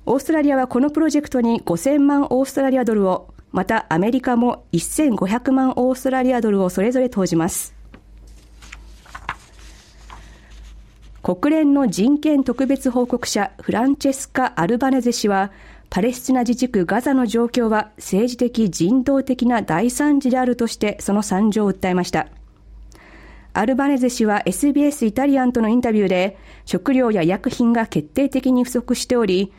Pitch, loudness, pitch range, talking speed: 245 Hz, -19 LUFS, 205-265 Hz, 320 characters per minute